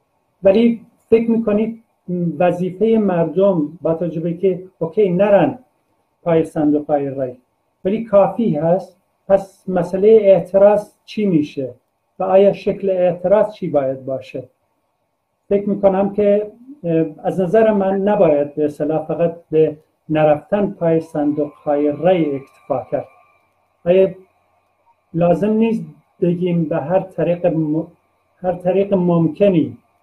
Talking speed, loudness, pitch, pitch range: 115 wpm, -17 LUFS, 180 Hz, 155-200 Hz